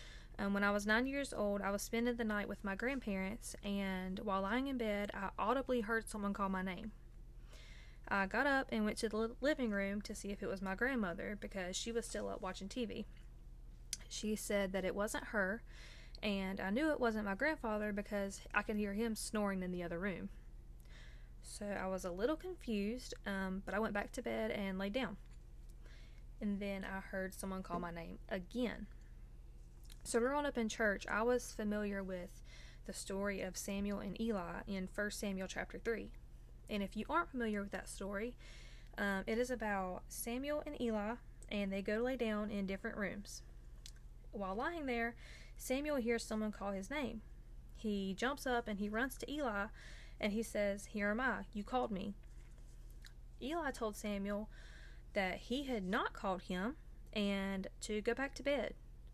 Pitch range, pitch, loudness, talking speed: 195-235 Hz, 210 Hz, -40 LUFS, 185 wpm